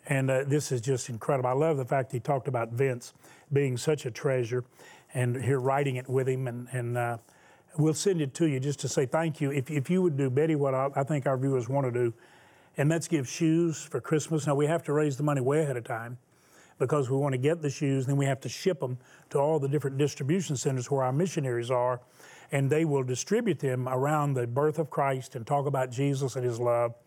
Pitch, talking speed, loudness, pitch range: 140 Hz, 245 wpm, -29 LUFS, 130-150 Hz